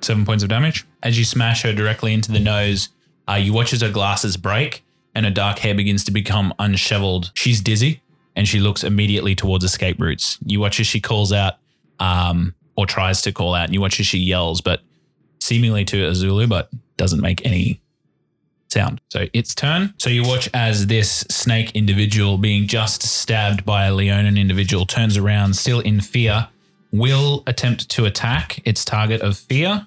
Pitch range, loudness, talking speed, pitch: 100-115 Hz, -18 LUFS, 185 wpm, 105 Hz